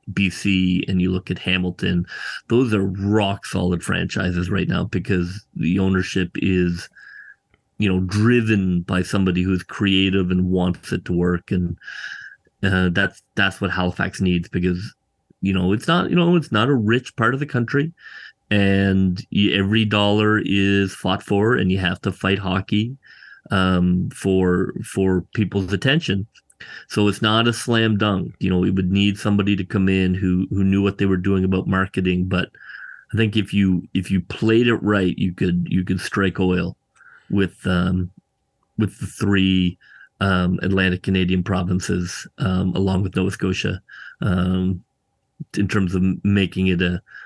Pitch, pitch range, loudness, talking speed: 95 Hz, 90-100 Hz, -20 LUFS, 165 wpm